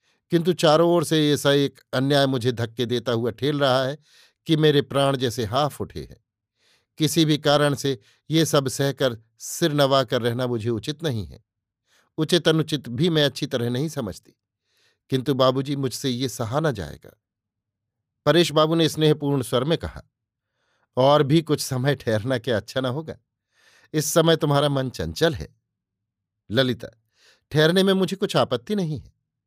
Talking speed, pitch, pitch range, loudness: 165 wpm, 140 Hz, 120-155 Hz, -22 LUFS